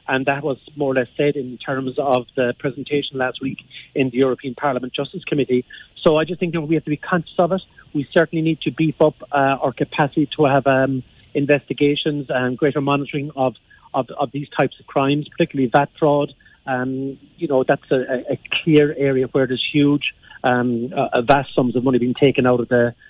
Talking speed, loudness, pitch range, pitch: 210 wpm, -20 LUFS, 130-150 Hz, 140 Hz